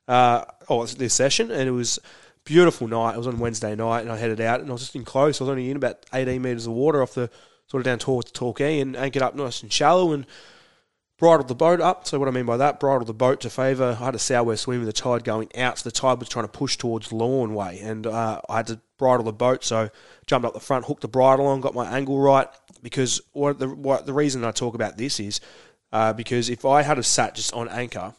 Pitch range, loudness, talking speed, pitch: 115-135 Hz, -23 LUFS, 275 wpm, 125 Hz